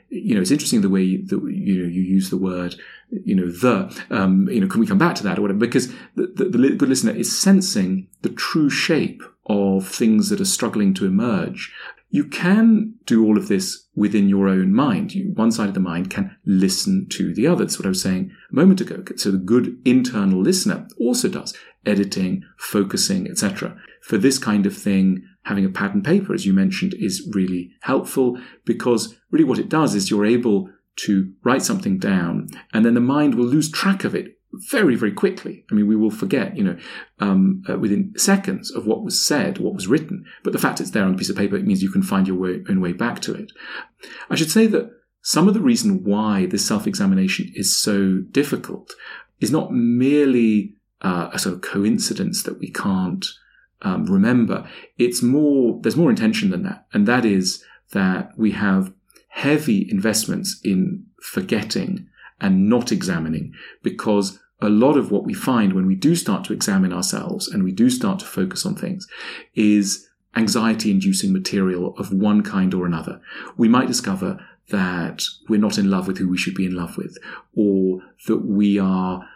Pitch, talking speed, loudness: 150 Hz, 200 wpm, -20 LUFS